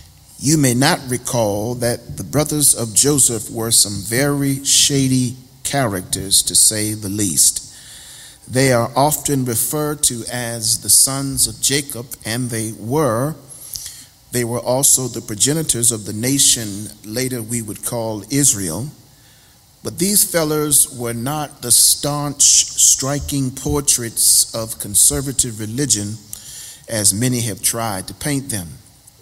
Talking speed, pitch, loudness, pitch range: 130 wpm, 125 Hz, -15 LUFS, 110-140 Hz